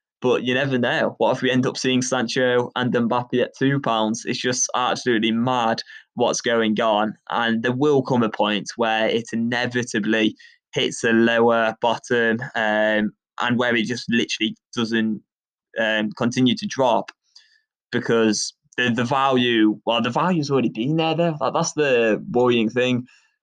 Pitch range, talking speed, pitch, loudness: 115-130 Hz, 160 wpm, 120 Hz, -21 LUFS